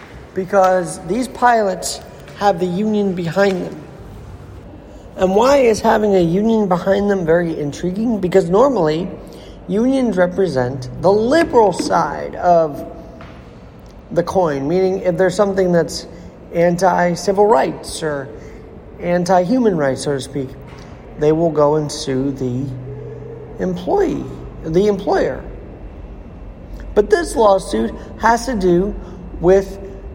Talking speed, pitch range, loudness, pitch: 115 wpm, 145-200 Hz, -16 LUFS, 180 Hz